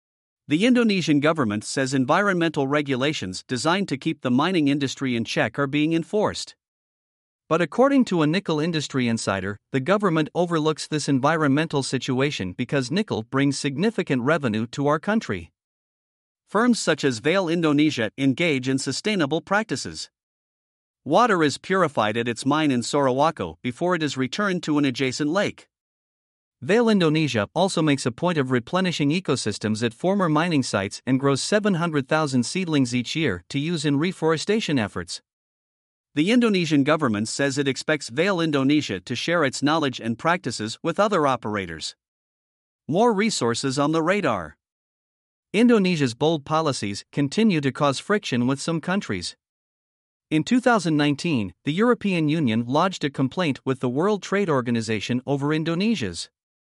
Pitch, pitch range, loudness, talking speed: 150 Hz, 130-170 Hz, -23 LUFS, 140 wpm